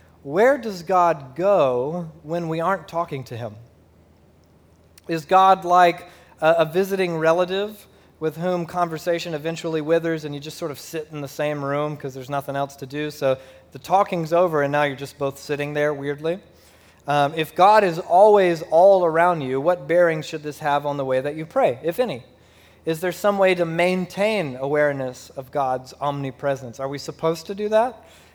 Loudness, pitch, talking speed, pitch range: -21 LUFS, 160 Hz, 185 wpm, 140-175 Hz